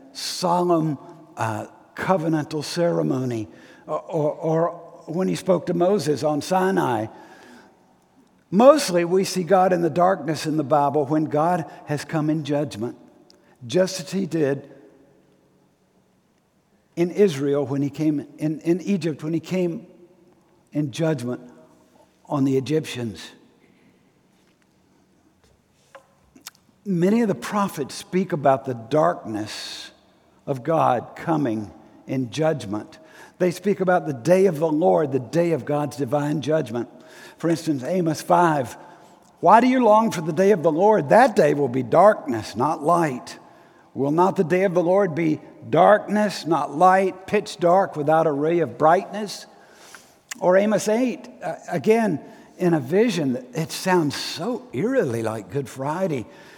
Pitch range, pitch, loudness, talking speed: 145-185 Hz, 165 Hz, -21 LUFS, 140 wpm